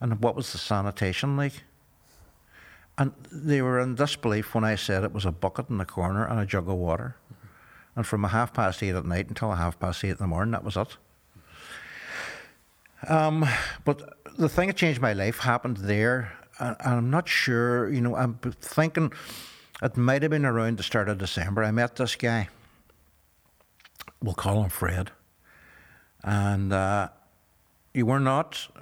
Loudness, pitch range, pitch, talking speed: -27 LUFS, 95-130 Hz, 115 Hz, 175 wpm